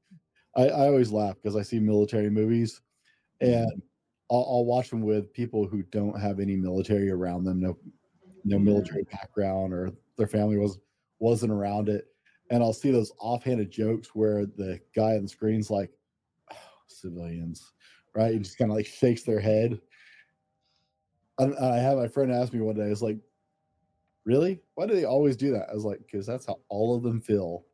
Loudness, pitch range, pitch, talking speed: -27 LUFS, 100-120 Hz, 110 Hz, 195 wpm